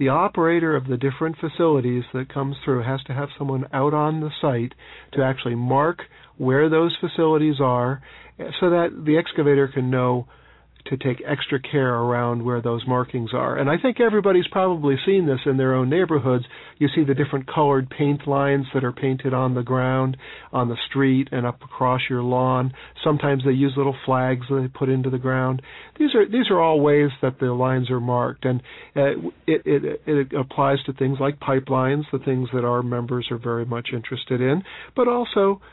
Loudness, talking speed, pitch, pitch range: -22 LUFS, 190 wpm, 135 Hz, 130-150 Hz